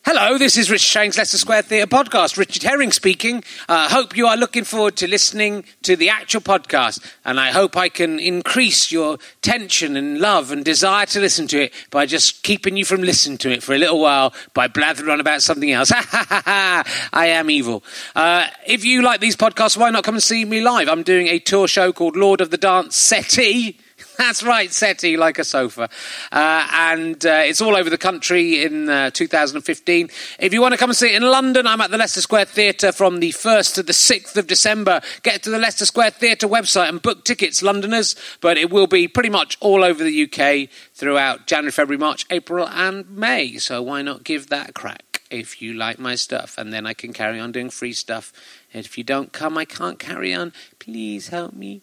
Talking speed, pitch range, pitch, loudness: 220 wpm, 155-220 Hz, 190 Hz, -16 LUFS